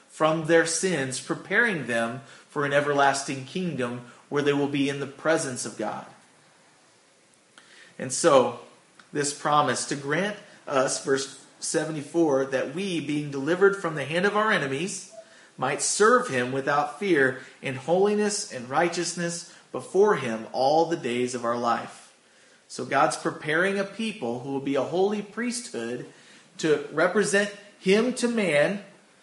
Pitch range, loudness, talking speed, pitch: 135-190 Hz, -25 LUFS, 145 wpm, 155 Hz